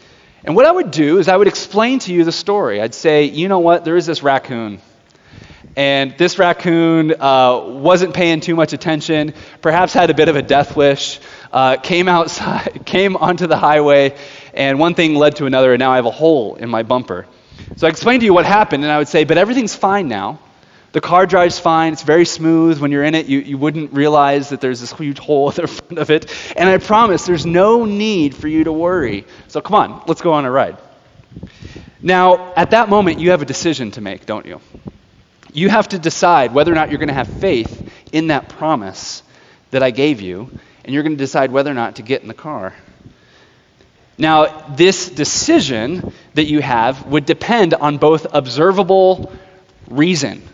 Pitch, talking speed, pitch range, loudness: 155 Hz, 210 wpm, 140-175 Hz, -14 LUFS